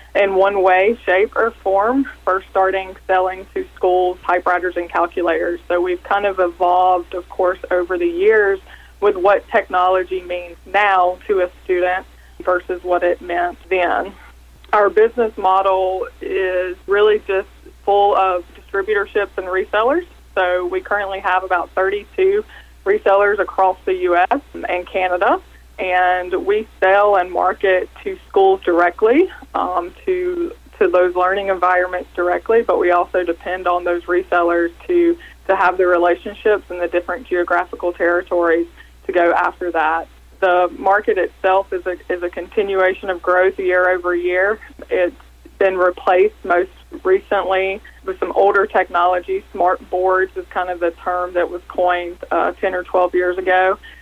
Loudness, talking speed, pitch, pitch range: -17 LUFS, 150 wpm, 185 Hz, 180-200 Hz